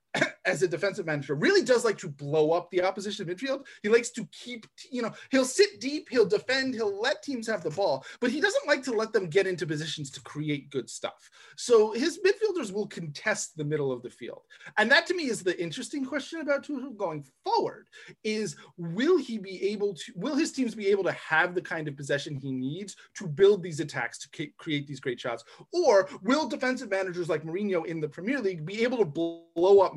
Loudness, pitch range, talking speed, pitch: -28 LUFS, 170-275 Hz, 220 wpm, 210 Hz